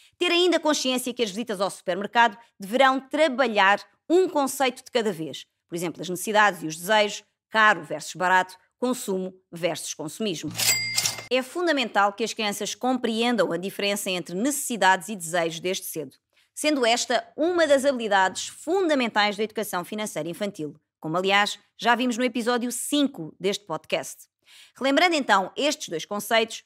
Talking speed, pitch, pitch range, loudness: 150 wpm, 215 Hz, 185-255 Hz, -24 LUFS